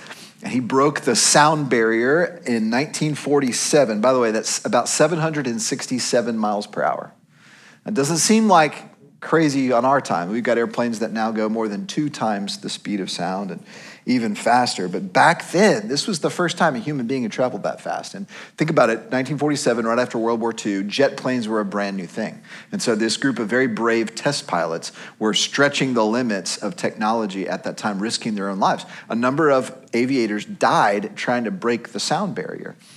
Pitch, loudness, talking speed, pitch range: 130 Hz, -20 LUFS, 195 wpm, 115-160 Hz